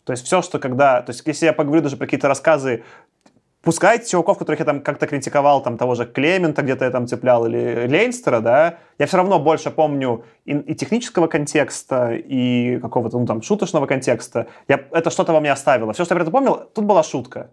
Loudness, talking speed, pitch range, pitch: -18 LUFS, 205 wpm, 125-170 Hz, 150 Hz